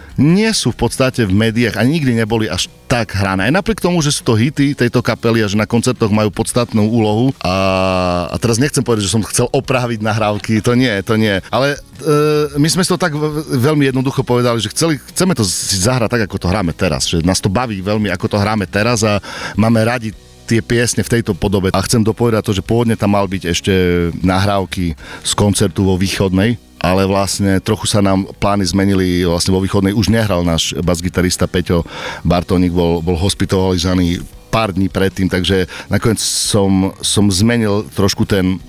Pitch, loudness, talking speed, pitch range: 105 Hz, -15 LUFS, 190 wpm, 95-120 Hz